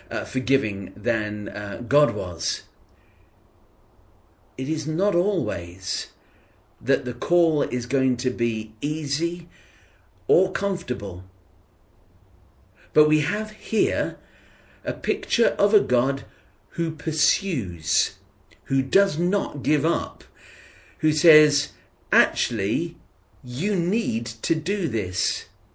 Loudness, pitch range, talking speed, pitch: -24 LUFS, 95-160 Hz, 105 wpm, 125 Hz